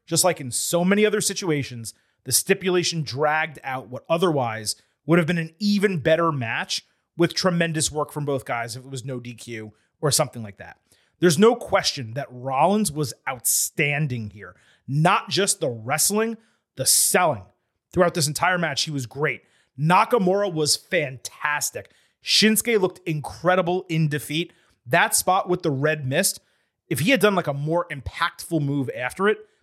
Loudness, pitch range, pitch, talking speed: -22 LUFS, 135-180 Hz, 155 Hz, 165 wpm